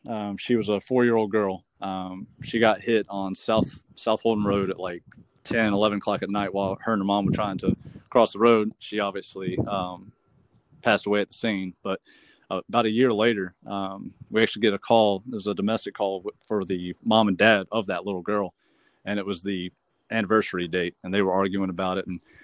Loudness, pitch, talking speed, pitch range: -25 LUFS, 100 Hz, 215 wpm, 95-110 Hz